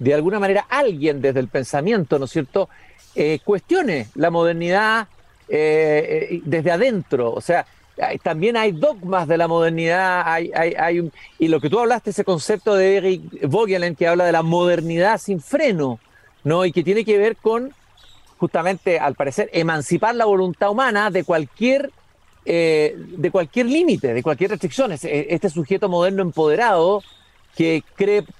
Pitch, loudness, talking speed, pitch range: 180 Hz, -19 LUFS, 160 wpm, 165-205 Hz